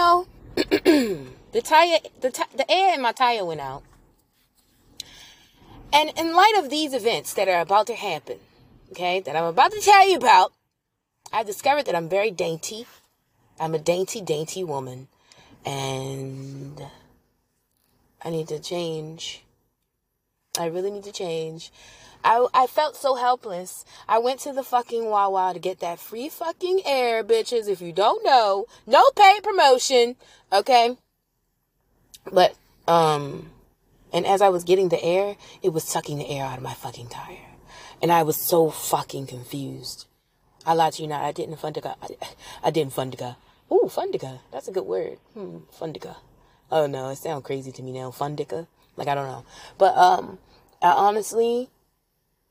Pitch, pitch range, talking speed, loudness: 185 Hz, 155-255 Hz, 160 wpm, -22 LUFS